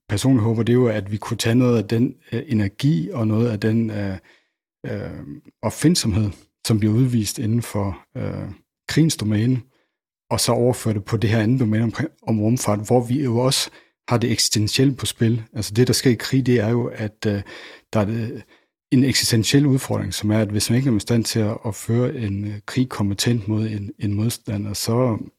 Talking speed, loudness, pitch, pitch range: 210 wpm, -21 LUFS, 115 Hz, 105-125 Hz